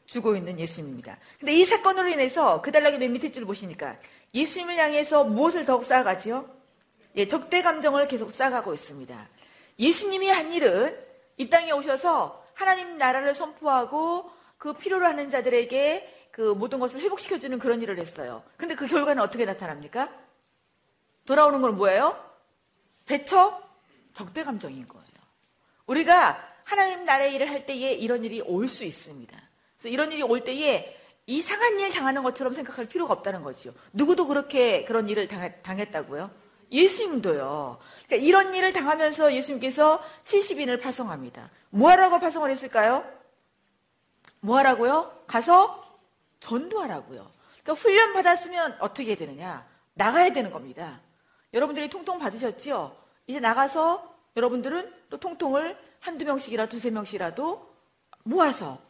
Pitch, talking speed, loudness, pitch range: 280 Hz, 345 characters per minute, -24 LUFS, 240-340 Hz